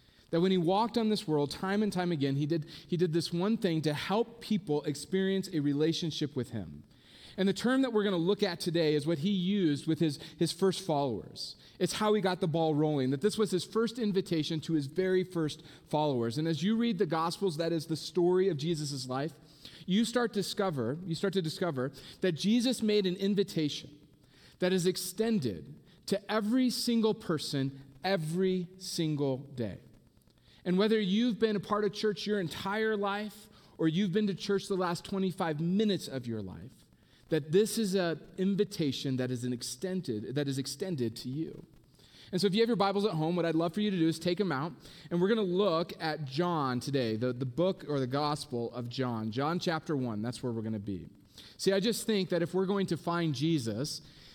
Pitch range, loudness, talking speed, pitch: 145-195 Hz, -32 LUFS, 210 wpm, 170 Hz